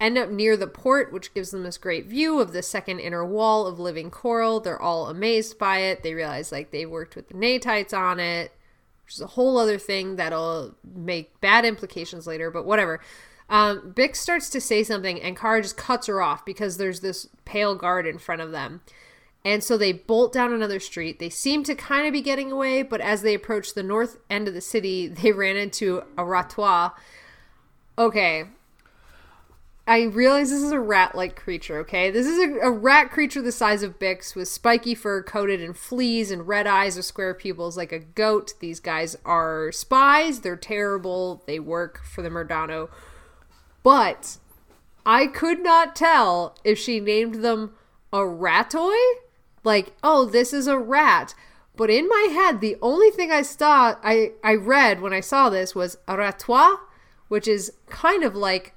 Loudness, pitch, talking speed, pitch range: -22 LUFS, 205 Hz, 190 wpm, 180-240 Hz